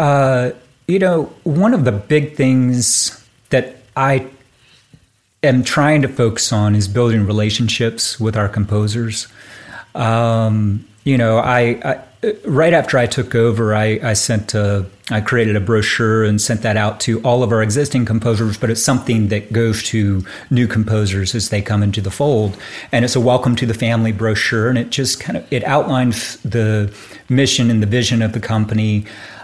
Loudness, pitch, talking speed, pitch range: -16 LUFS, 115 Hz, 175 wpm, 110-125 Hz